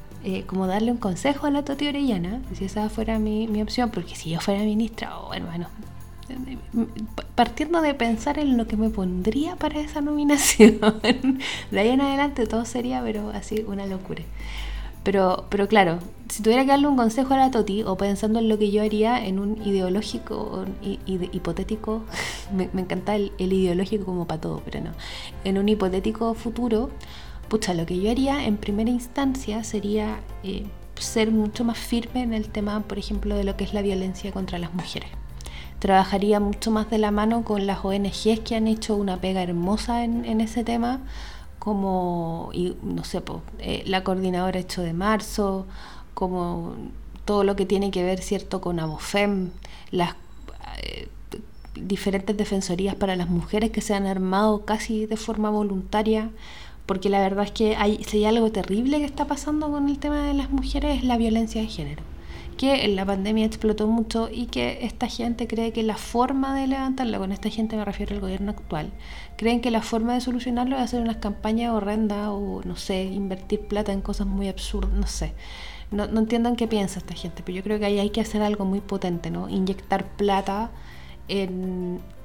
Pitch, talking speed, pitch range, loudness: 210 Hz, 190 wpm, 195-230 Hz, -25 LUFS